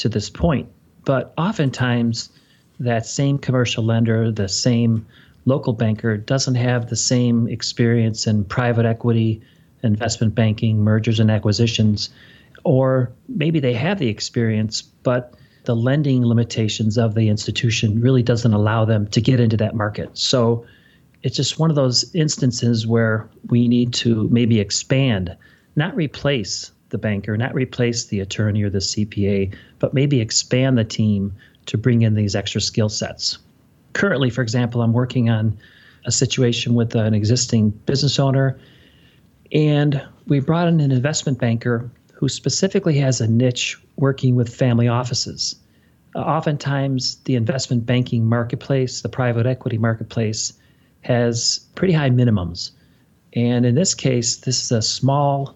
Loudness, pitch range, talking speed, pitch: -19 LUFS, 110-130 Hz, 145 wpm, 120 Hz